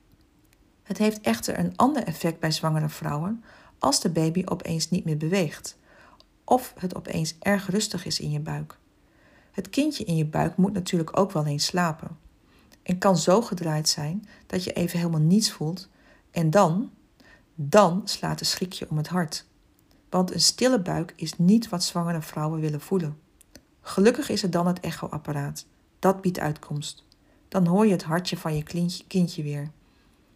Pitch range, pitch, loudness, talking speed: 155-195 Hz, 175 Hz, -25 LUFS, 170 wpm